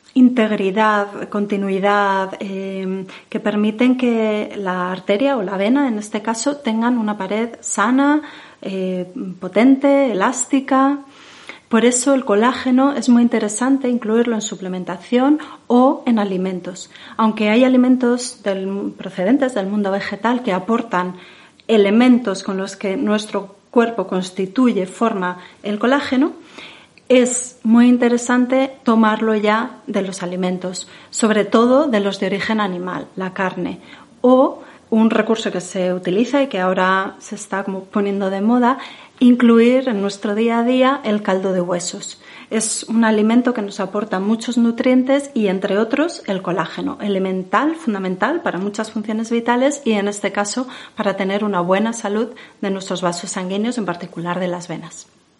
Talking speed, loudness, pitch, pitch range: 145 wpm, -18 LUFS, 215 Hz, 195-245 Hz